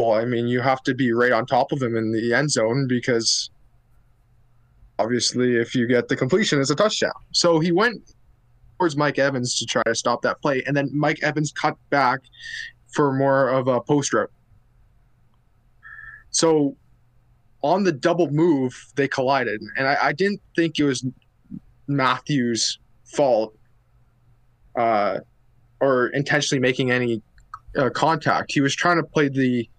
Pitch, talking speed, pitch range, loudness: 130 Hz, 155 wpm, 120-145 Hz, -21 LUFS